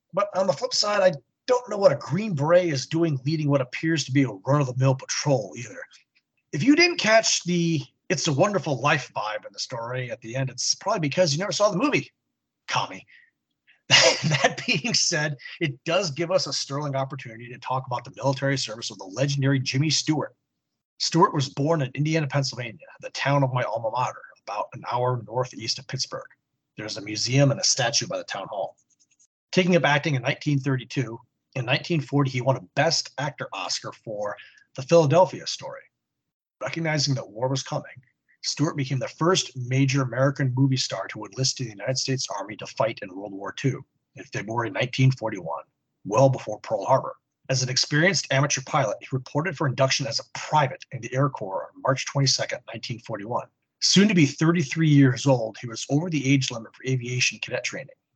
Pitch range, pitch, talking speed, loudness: 130-160 Hz, 140 Hz, 190 wpm, -24 LUFS